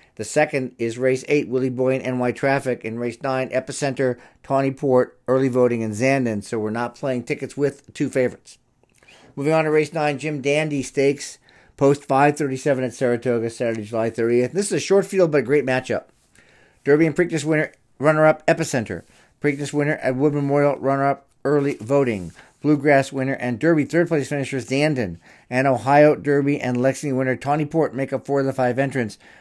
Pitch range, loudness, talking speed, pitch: 125-145 Hz, -21 LUFS, 190 wpm, 135 Hz